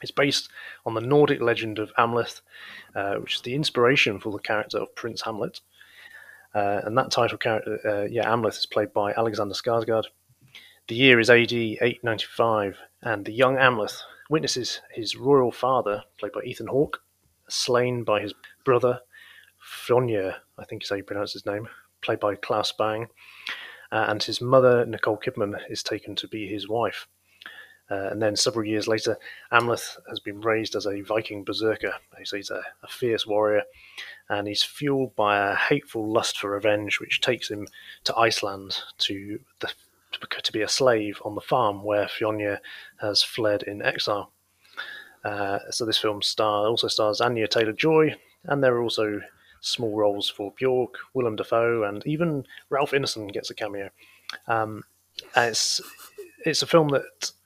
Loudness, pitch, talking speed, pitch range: -25 LUFS, 110 Hz, 165 wpm, 105-125 Hz